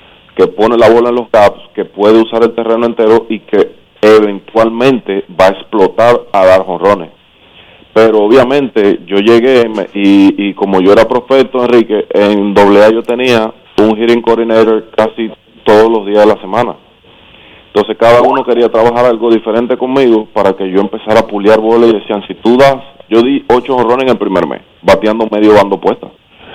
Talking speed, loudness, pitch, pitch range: 180 wpm, -9 LUFS, 110 Hz, 105-115 Hz